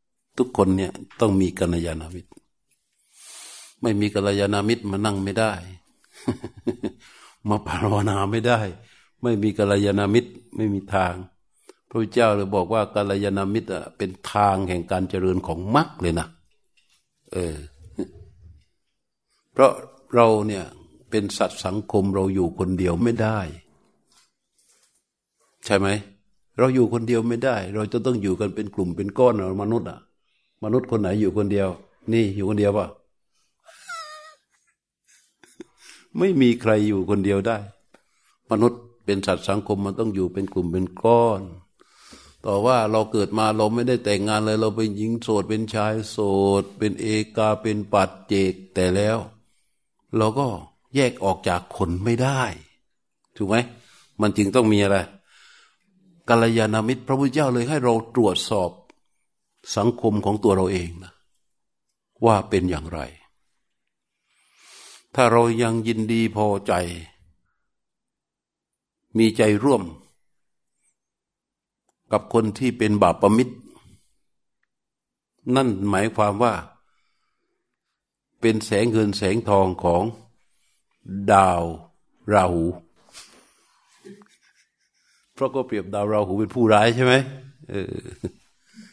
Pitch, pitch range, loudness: 105 Hz, 95-115 Hz, -22 LUFS